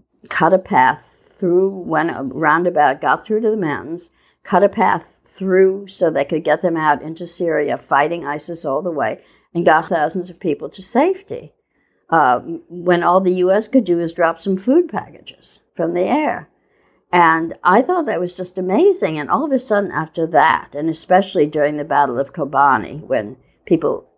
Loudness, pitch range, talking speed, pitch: -17 LUFS, 155-190 Hz, 185 wpm, 175 Hz